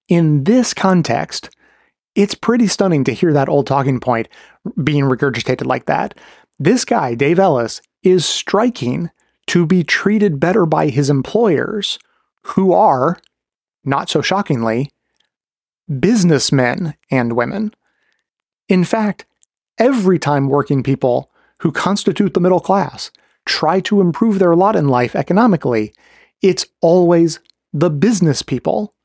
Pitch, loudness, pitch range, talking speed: 170 Hz, -15 LUFS, 140-200 Hz, 125 wpm